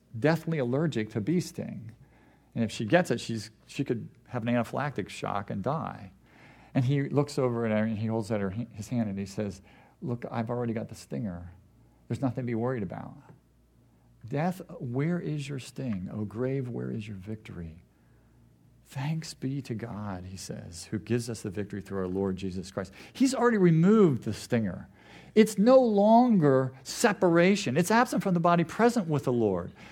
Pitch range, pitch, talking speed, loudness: 105-155 Hz, 120 Hz, 185 wpm, -28 LUFS